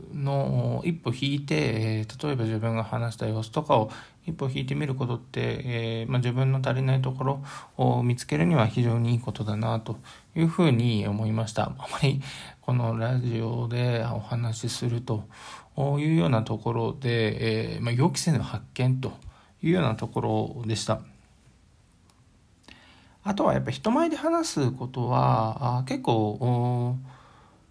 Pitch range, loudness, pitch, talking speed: 110-135 Hz, -27 LUFS, 120 Hz, 290 characters per minute